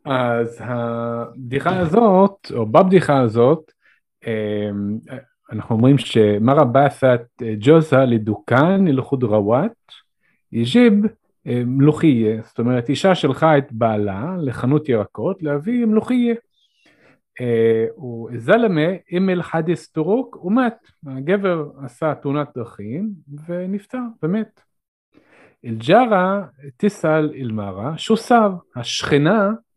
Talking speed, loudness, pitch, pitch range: 95 wpm, -18 LUFS, 145 Hz, 120-190 Hz